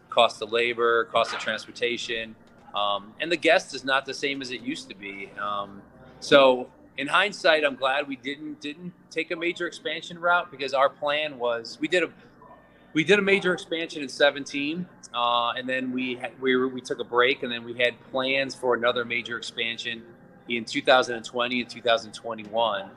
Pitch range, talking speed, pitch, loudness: 120-145 Hz, 185 wpm, 130 Hz, -25 LUFS